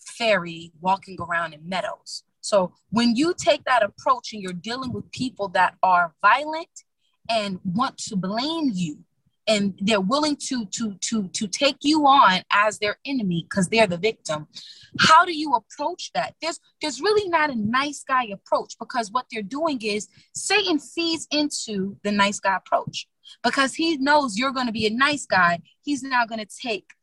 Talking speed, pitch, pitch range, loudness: 180 wpm, 235 Hz, 200-295 Hz, -23 LUFS